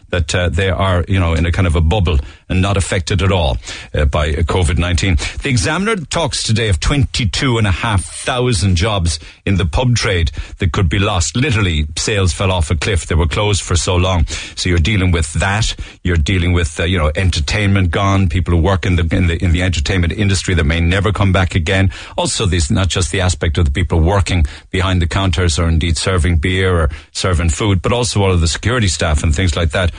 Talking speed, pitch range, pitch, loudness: 215 wpm, 85-100 Hz, 90 Hz, -15 LUFS